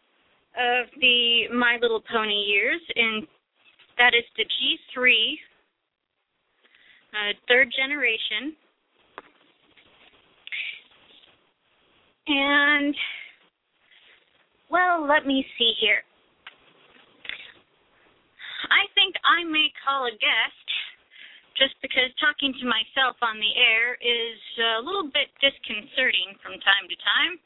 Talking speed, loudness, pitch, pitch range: 95 wpm, -22 LUFS, 250 Hz, 230-290 Hz